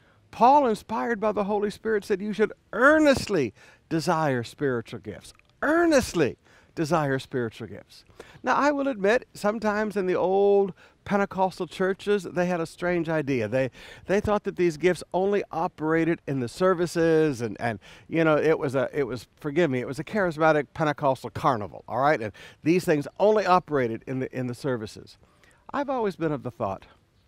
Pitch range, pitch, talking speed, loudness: 130-200 Hz, 165 Hz, 170 wpm, -25 LUFS